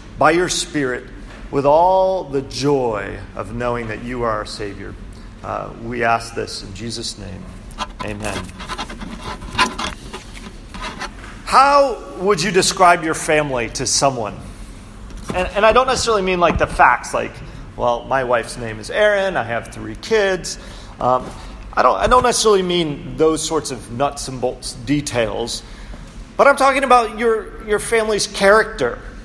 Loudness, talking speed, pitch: -18 LUFS, 150 wpm, 135 Hz